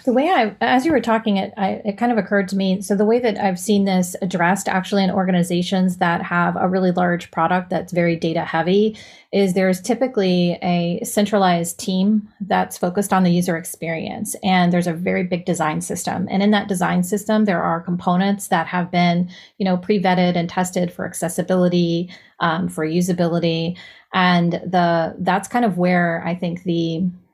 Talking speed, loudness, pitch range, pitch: 190 wpm, -19 LUFS, 175-200 Hz, 185 Hz